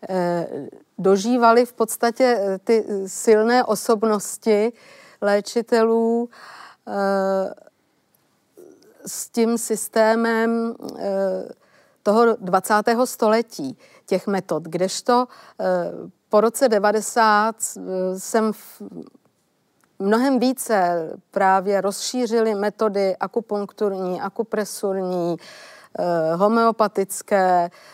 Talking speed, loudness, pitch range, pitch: 60 wpm, -21 LUFS, 195-230 Hz, 215 Hz